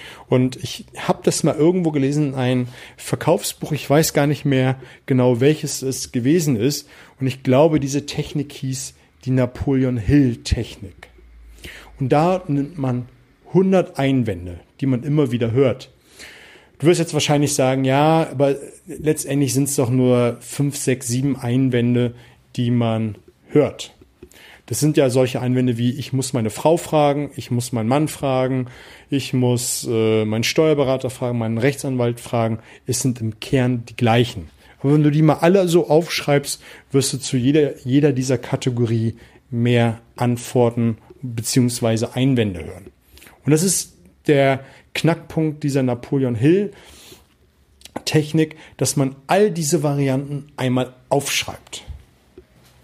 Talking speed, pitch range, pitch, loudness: 140 wpm, 120-145 Hz, 130 Hz, -19 LUFS